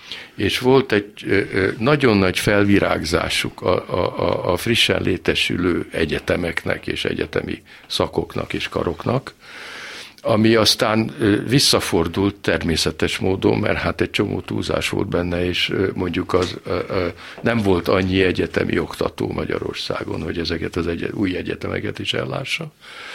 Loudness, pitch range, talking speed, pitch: -20 LUFS, 85-110 Hz, 125 wpm, 95 Hz